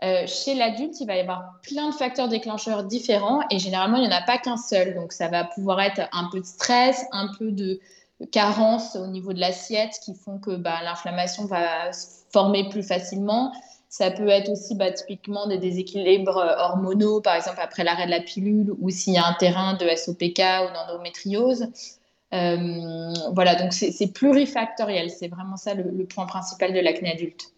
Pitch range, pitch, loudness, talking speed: 180-215 Hz, 190 Hz, -24 LUFS, 195 wpm